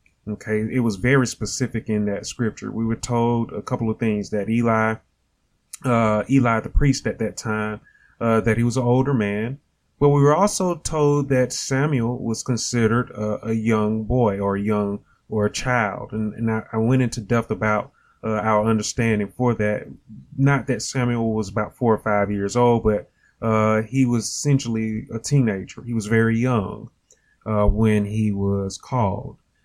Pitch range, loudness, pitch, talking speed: 105-125 Hz, -22 LUFS, 110 Hz, 180 wpm